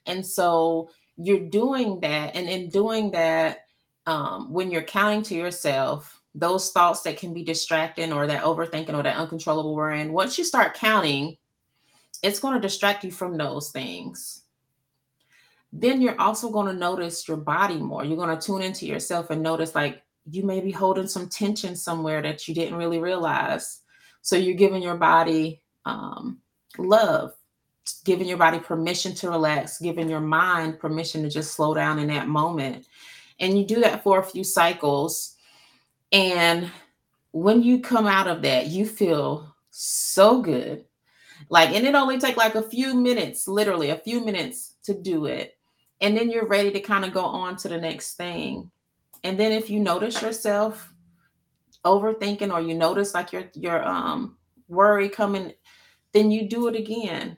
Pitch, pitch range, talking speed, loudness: 180 Hz, 160-205 Hz, 170 wpm, -23 LUFS